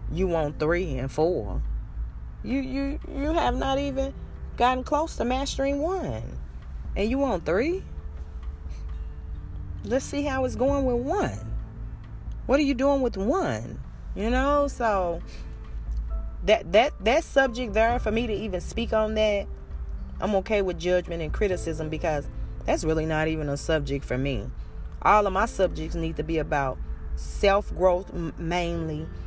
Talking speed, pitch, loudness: 150 wpm, 170 Hz, -26 LUFS